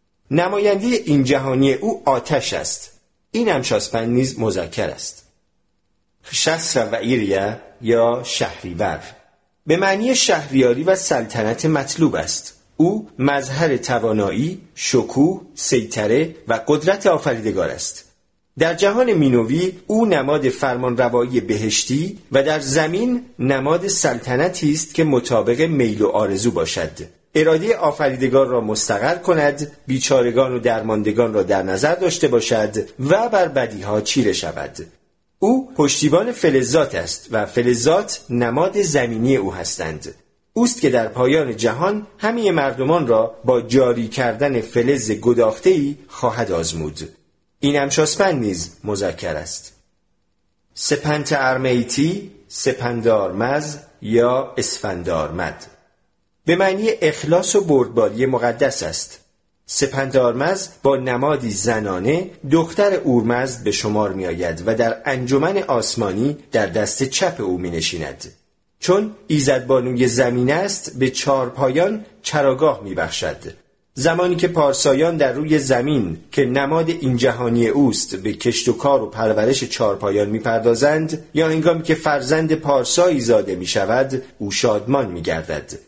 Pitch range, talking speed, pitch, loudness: 120-160 Hz, 120 wpm, 135 Hz, -18 LUFS